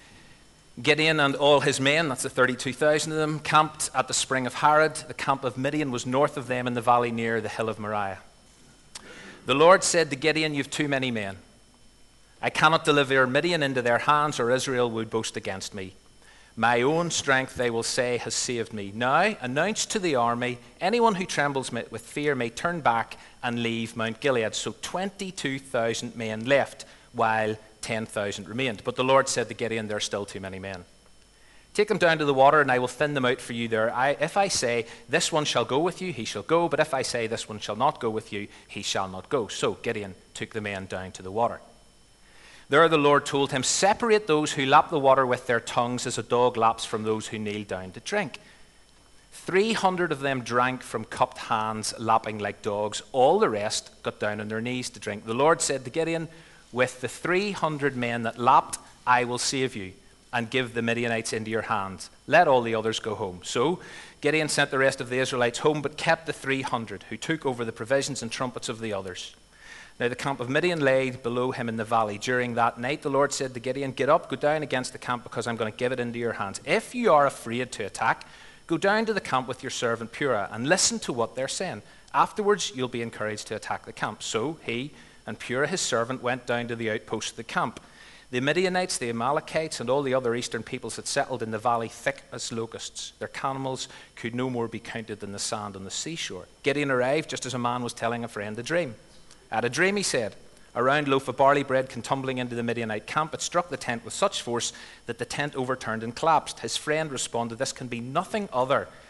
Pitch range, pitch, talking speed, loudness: 115-145 Hz, 125 Hz, 225 wpm, -26 LUFS